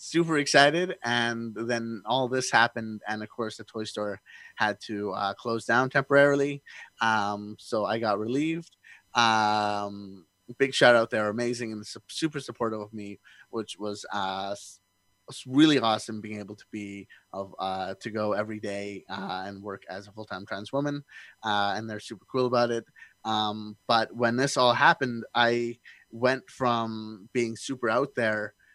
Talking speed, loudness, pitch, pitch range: 165 wpm, -27 LUFS, 110 Hz, 105-125 Hz